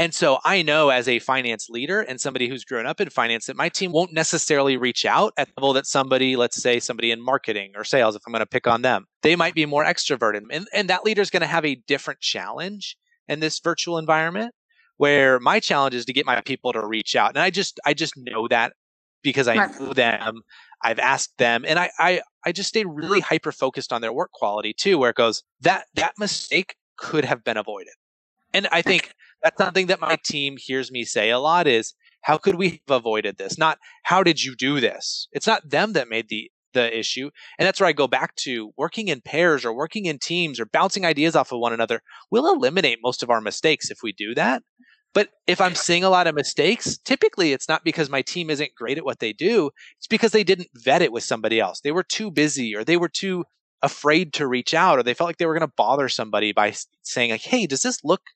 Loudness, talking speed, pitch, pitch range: -21 LUFS, 240 wpm, 145 Hz, 125-175 Hz